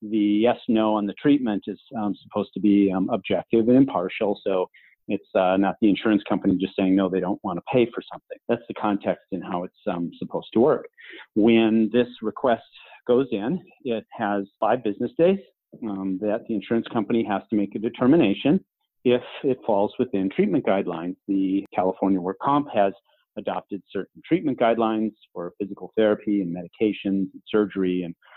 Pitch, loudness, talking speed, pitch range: 105 Hz, -24 LUFS, 180 wpm, 95-115 Hz